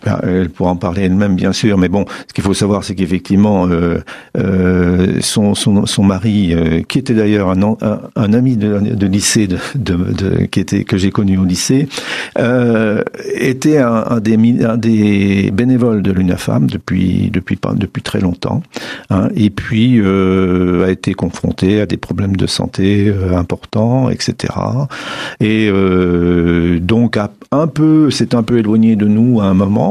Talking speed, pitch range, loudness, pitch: 175 wpm, 95-115 Hz, -13 LUFS, 100 Hz